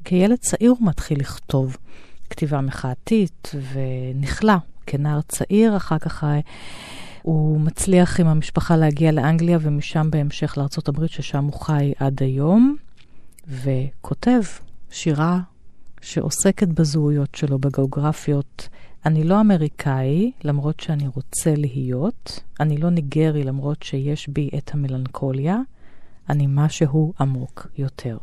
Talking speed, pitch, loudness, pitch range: 105 wpm, 150 Hz, -21 LUFS, 140-165 Hz